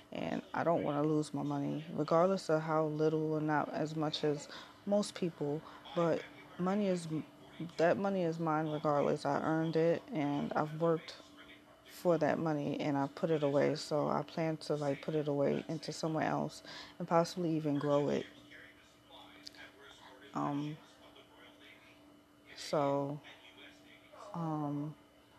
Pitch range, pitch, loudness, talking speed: 145-165 Hz, 155 Hz, -35 LUFS, 140 wpm